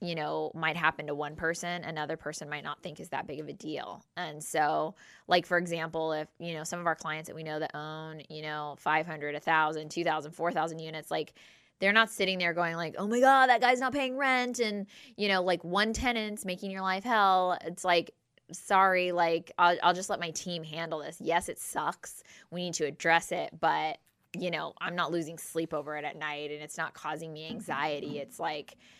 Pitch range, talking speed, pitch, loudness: 155-185 Hz, 220 wpm, 165 Hz, -30 LUFS